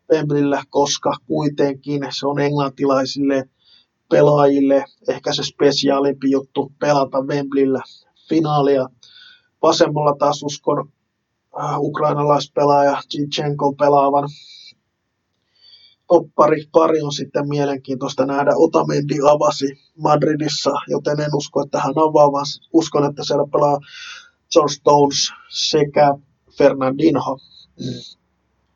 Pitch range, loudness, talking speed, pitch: 140-150 Hz, -17 LUFS, 95 wpm, 145 Hz